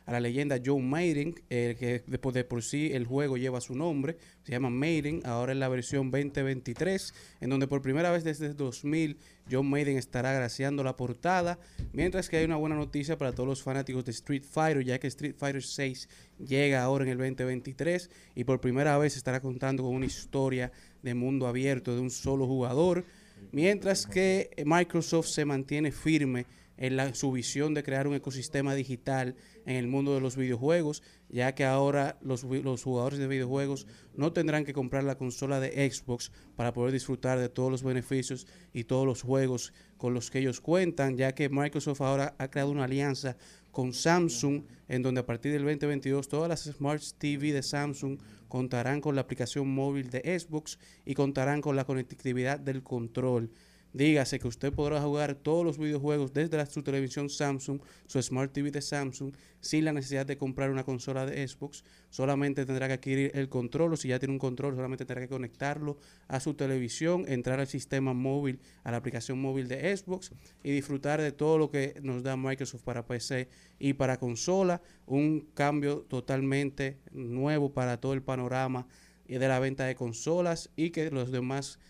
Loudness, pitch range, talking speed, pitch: -31 LUFS, 130-145 Hz, 185 wpm, 135 Hz